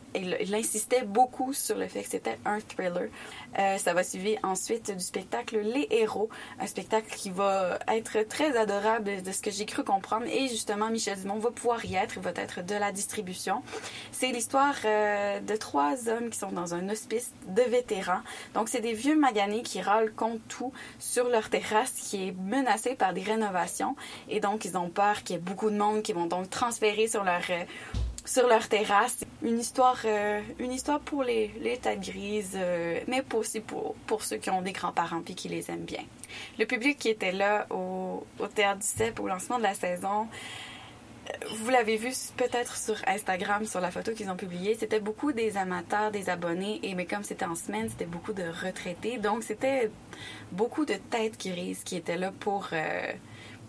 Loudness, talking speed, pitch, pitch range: -30 LUFS, 200 wpm, 215 Hz, 195-235 Hz